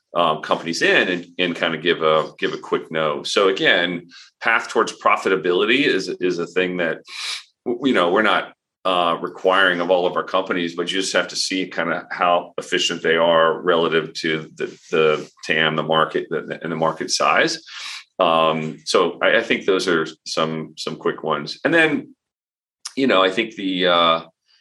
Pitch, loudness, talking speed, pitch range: 85 Hz, -19 LUFS, 190 wpm, 80-90 Hz